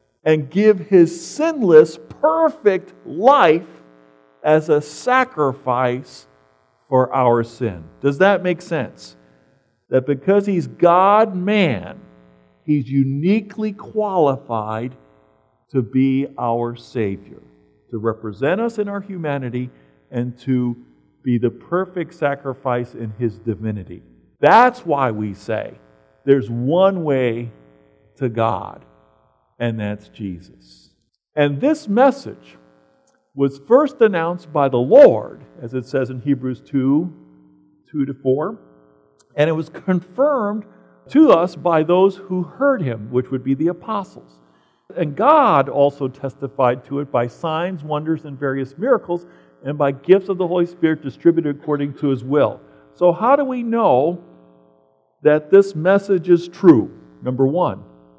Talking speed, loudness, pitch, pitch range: 130 wpm, -18 LUFS, 135 Hz, 105-175 Hz